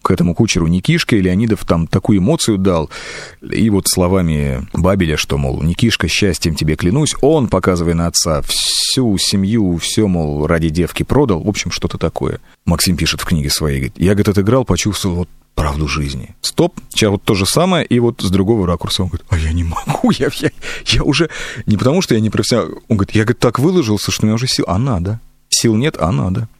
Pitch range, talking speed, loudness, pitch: 85-110 Hz, 210 wpm, -15 LUFS, 95 Hz